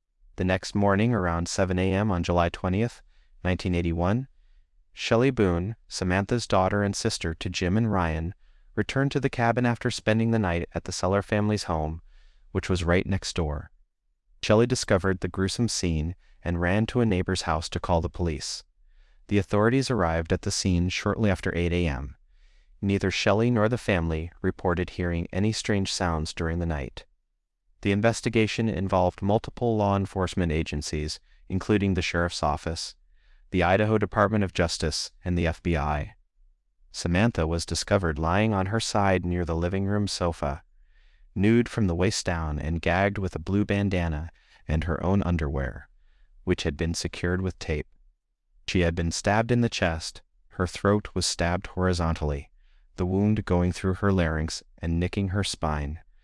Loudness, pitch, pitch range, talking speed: -26 LUFS, 90 Hz, 85-100 Hz, 165 wpm